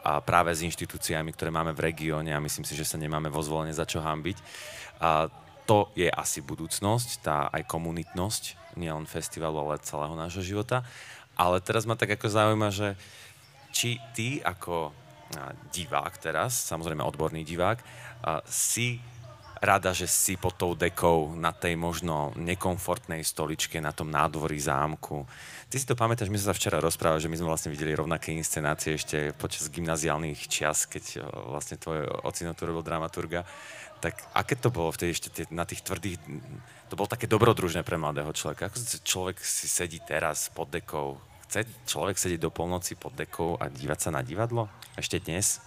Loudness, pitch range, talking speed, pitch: -29 LUFS, 80-105 Hz, 170 wpm, 85 Hz